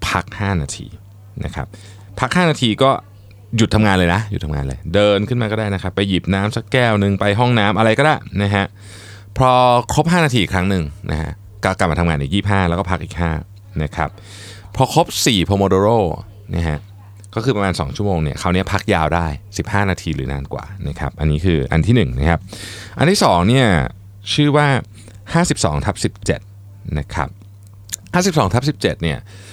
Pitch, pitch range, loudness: 100 Hz, 90-110 Hz, -17 LUFS